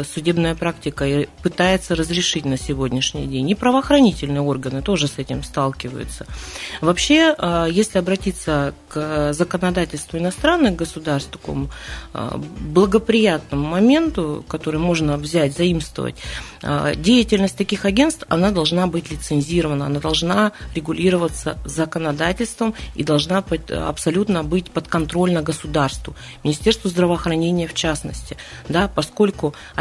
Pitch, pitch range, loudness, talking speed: 170 Hz, 150-190 Hz, -19 LUFS, 110 wpm